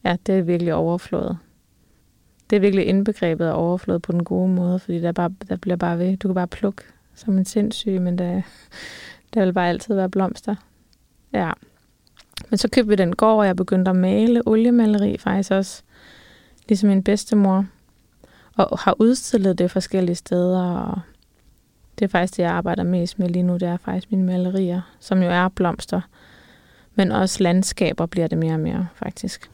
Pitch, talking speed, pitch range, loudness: 190 Hz, 180 wpm, 180-205 Hz, -21 LUFS